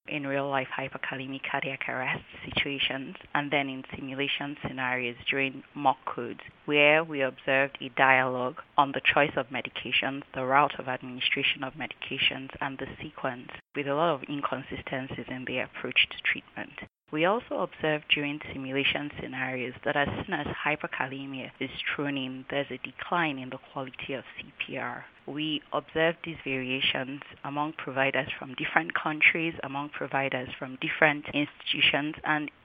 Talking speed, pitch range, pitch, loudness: 150 wpm, 130-145 Hz, 140 Hz, -29 LUFS